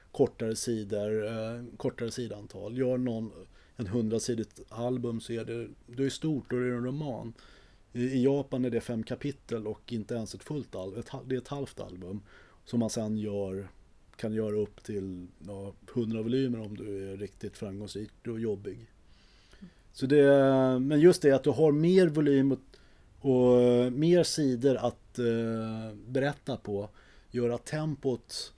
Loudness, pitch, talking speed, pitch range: -30 LUFS, 120 Hz, 160 wpm, 105-130 Hz